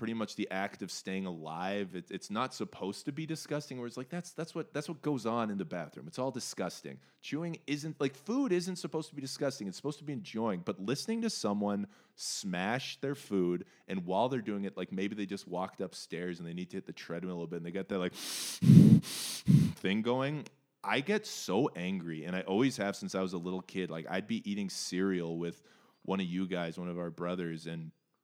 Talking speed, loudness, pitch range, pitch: 230 wpm, -34 LUFS, 90-145 Hz, 100 Hz